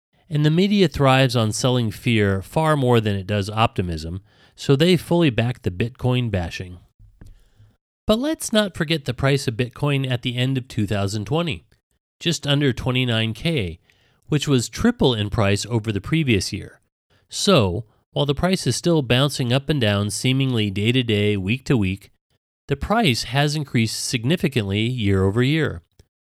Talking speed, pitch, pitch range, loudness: 160 wpm, 125 Hz, 105-145 Hz, -21 LUFS